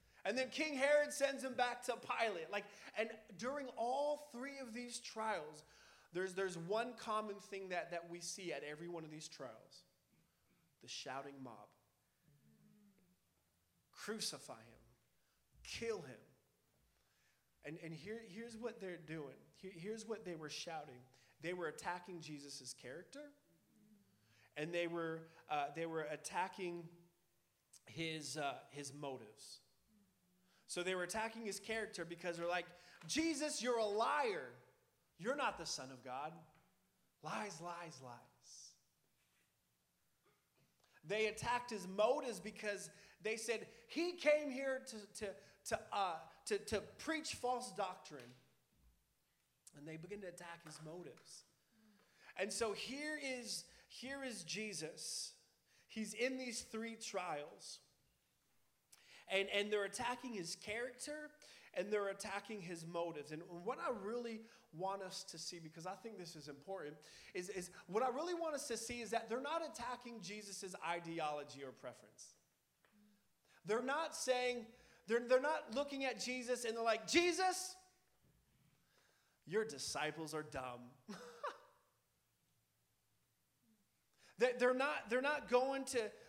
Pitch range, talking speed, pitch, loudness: 170-245 Hz, 135 wpm, 205 Hz, -43 LUFS